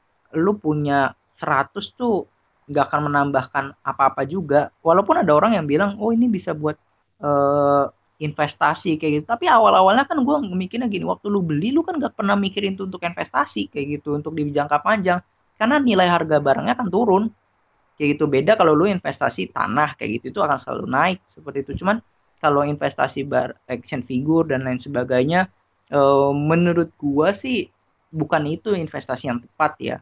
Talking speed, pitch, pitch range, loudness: 170 wpm, 155 Hz, 140-200 Hz, -20 LUFS